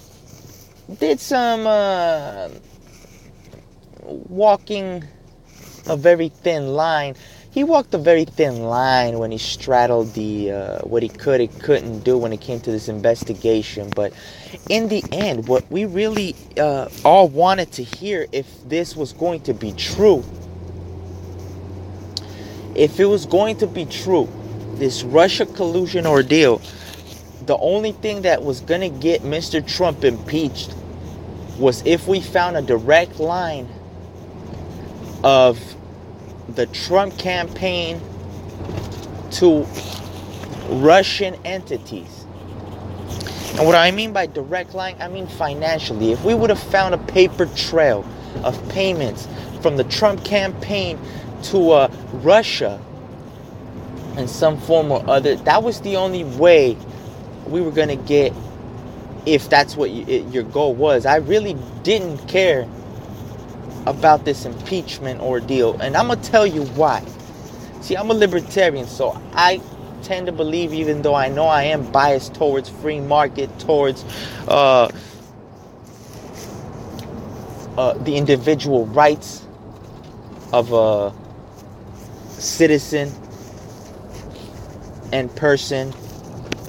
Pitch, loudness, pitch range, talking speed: 130 Hz, -18 LUFS, 110-170 Hz, 125 wpm